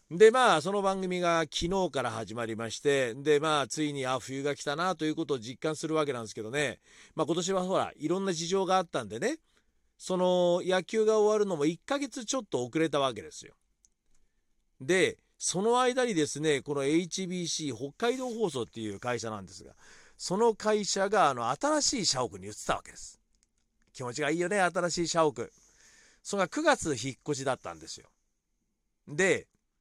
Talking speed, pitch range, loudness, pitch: 345 characters per minute, 135-190 Hz, -29 LUFS, 160 Hz